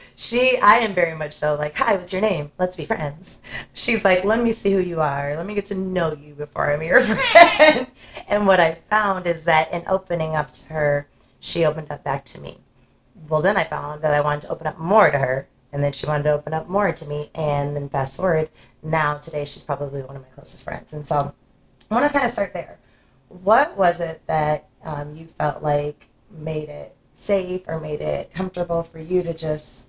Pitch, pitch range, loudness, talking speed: 155 Hz, 150-185 Hz, -20 LUFS, 225 wpm